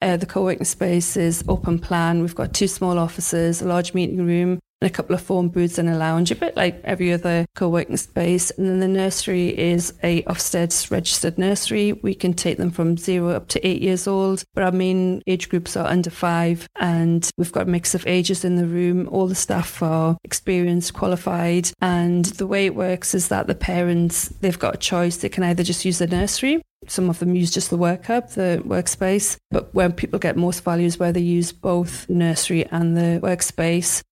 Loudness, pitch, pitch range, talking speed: -21 LUFS, 175 Hz, 170-185 Hz, 210 wpm